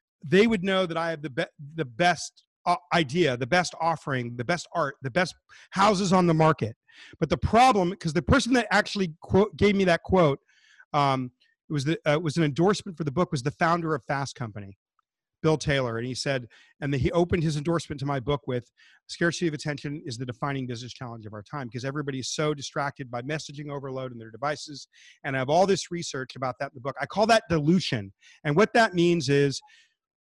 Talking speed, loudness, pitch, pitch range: 220 wpm, -26 LUFS, 155 Hz, 135-175 Hz